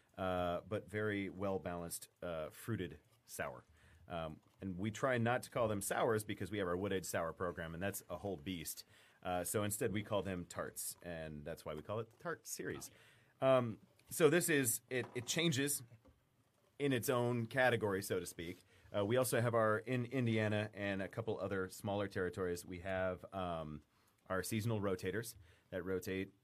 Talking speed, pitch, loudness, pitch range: 180 wpm, 100 Hz, -39 LUFS, 95-115 Hz